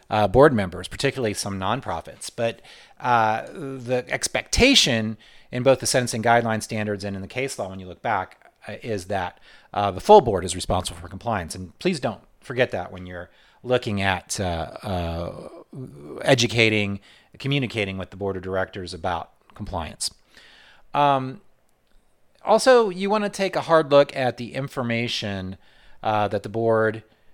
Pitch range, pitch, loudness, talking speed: 95-130 Hz, 110 Hz, -23 LUFS, 160 wpm